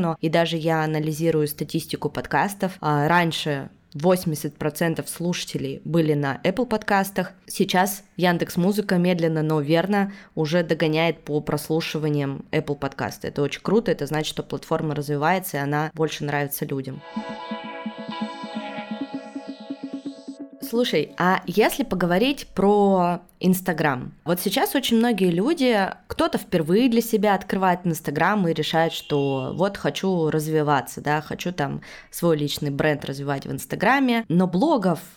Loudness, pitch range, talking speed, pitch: -23 LUFS, 155-195 Hz, 125 wpm, 170 Hz